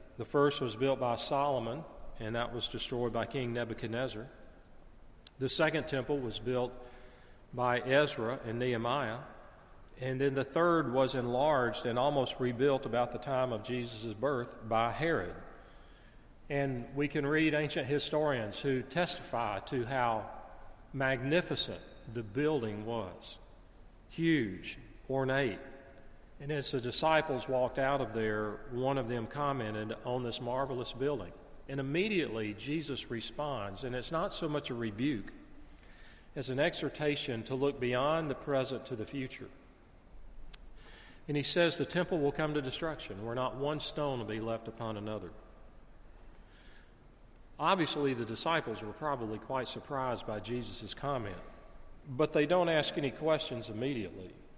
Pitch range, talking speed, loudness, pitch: 115-145 Hz, 140 wpm, -34 LUFS, 130 Hz